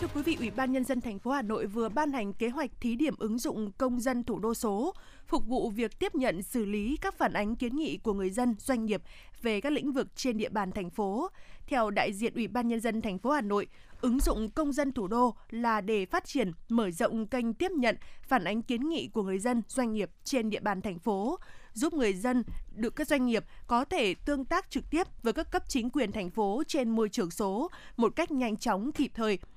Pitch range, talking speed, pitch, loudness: 215-280 Hz, 245 wpm, 240 Hz, -31 LUFS